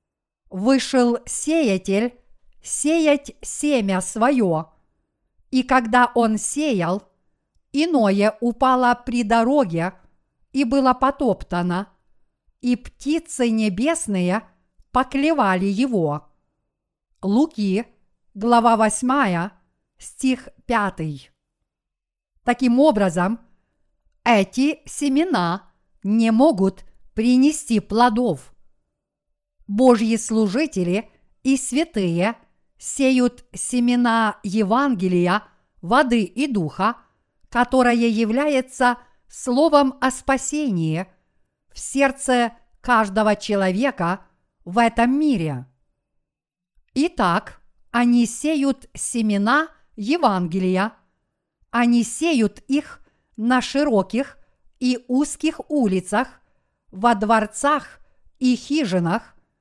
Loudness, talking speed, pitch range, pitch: -20 LUFS, 75 wpm, 200-265 Hz, 235 Hz